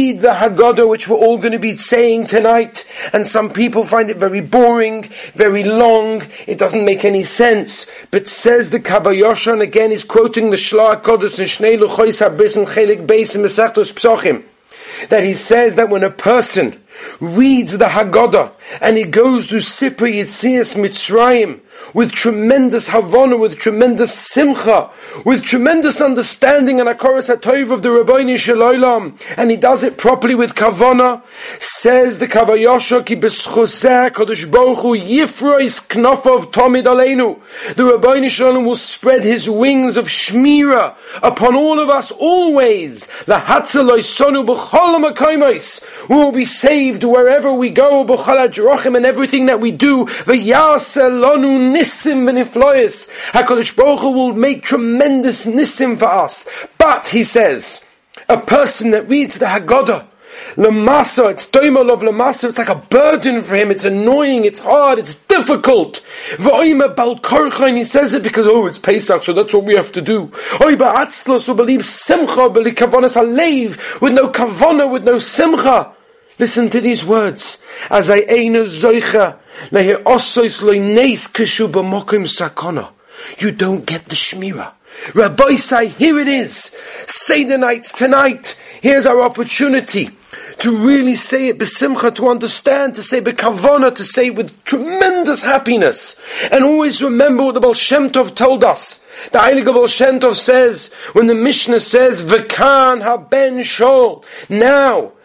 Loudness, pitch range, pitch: -12 LUFS, 225-270 Hz, 245 Hz